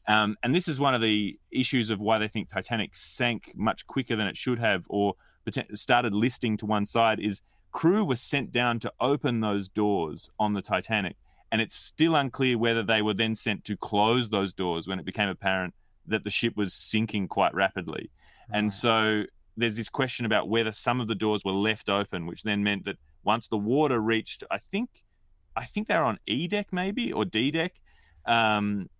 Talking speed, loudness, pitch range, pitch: 200 wpm, -27 LUFS, 100-120 Hz, 110 Hz